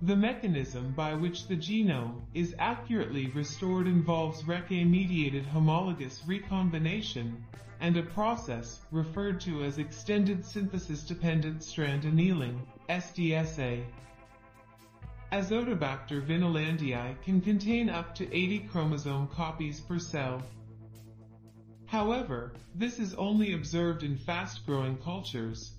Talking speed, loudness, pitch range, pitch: 100 wpm, -32 LUFS, 130-180 Hz, 160 Hz